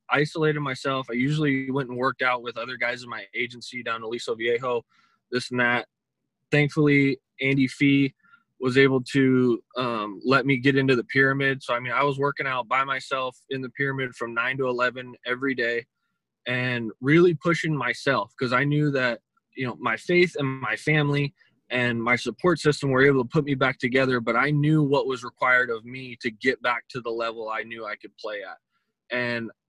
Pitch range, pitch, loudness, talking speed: 120-140 Hz, 130 Hz, -24 LUFS, 200 wpm